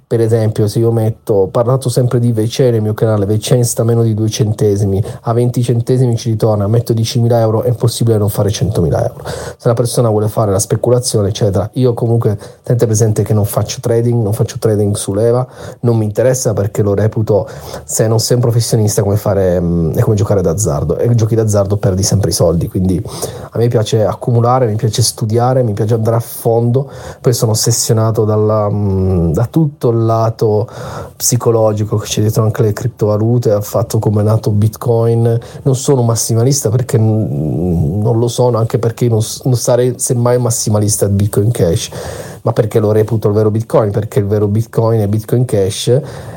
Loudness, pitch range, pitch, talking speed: -13 LUFS, 105-120 Hz, 115 Hz, 185 wpm